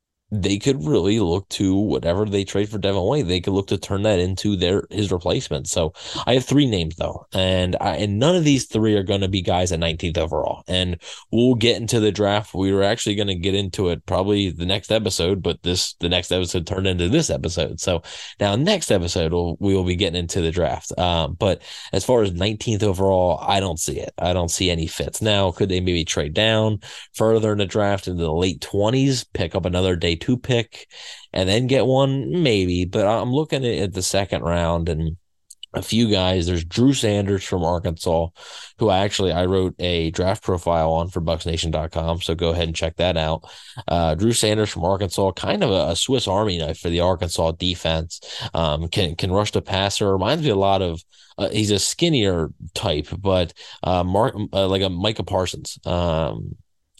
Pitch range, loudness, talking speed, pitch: 85-105 Hz, -21 LUFS, 205 wpm, 95 Hz